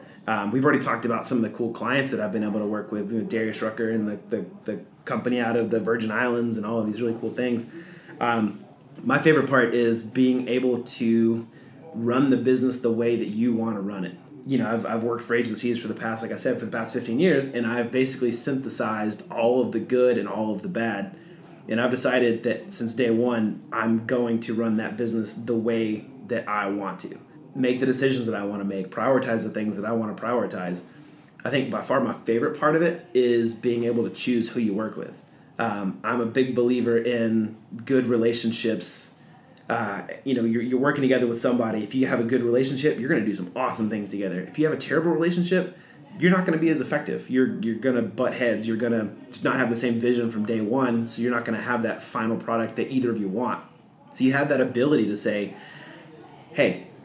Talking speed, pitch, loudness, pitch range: 235 wpm, 115 Hz, -25 LUFS, 110-125 Hz